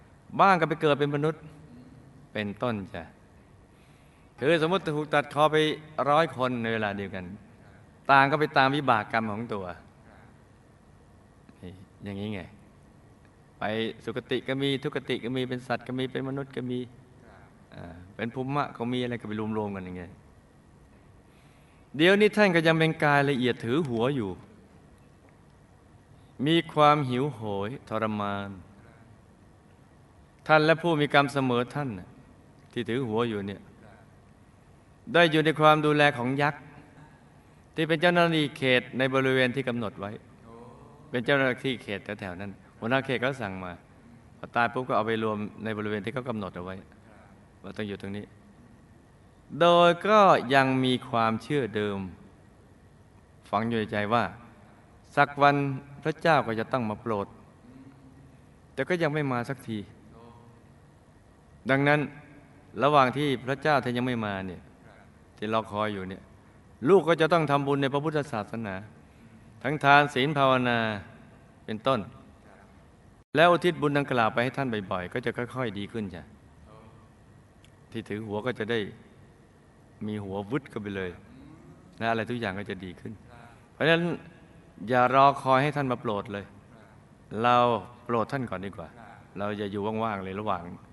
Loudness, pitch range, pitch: -26 LUFS, 105-140 Hz, 120 Hz